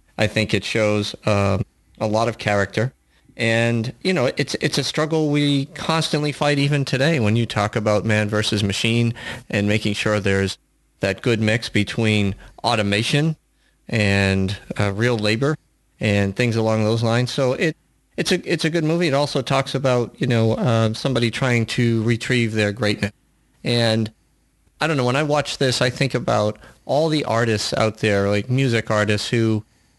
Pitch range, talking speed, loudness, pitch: 105-135 Hz, 175 wpm, -20 LUFS, 115 Hz